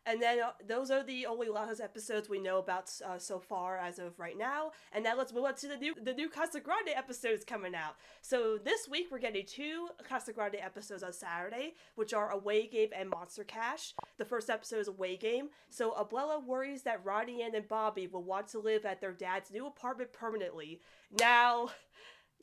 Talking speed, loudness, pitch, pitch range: 205 wpm, -37 LUFS, 225 Hz, 195-260 Hz